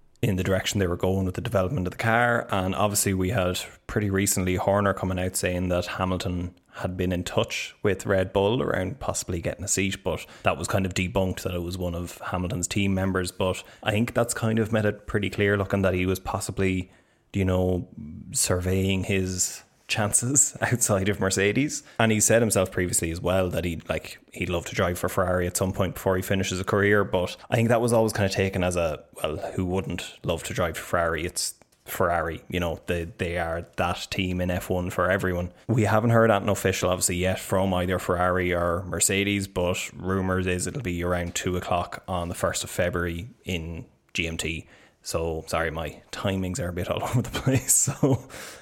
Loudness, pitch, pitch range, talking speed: -25 LUFS, 95 Hz, 90-100 Hz, 205 wpm